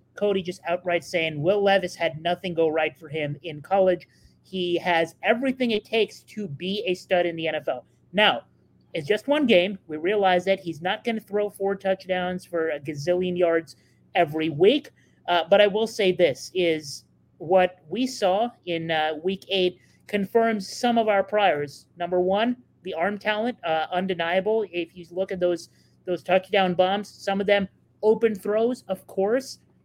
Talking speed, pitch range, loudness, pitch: 175 wpm, 170-205 Hz, -24 LUFS, 185 Hz